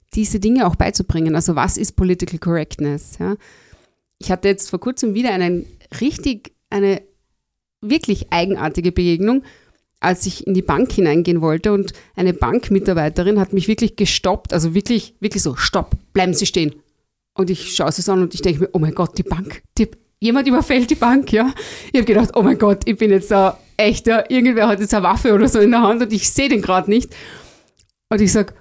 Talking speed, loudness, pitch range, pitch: 195 wpm, -17 LUFS, 180-220 Hz, 200 Hz